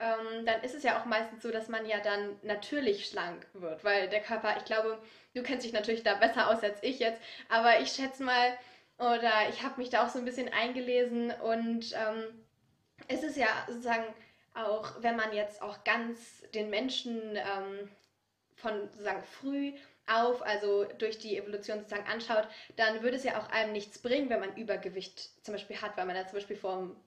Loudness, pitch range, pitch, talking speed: -33 LUFS, 210-235 Hz, 220 Hz, 195 wpm